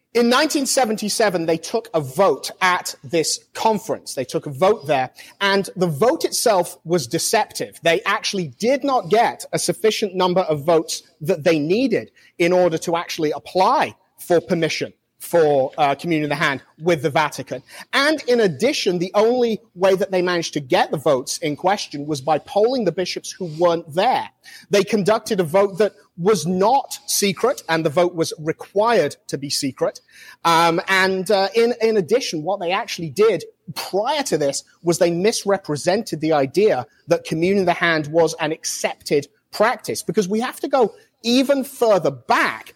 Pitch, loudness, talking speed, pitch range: 185 Hz, -20 LUFS, 175 wpm, 165-220 Hz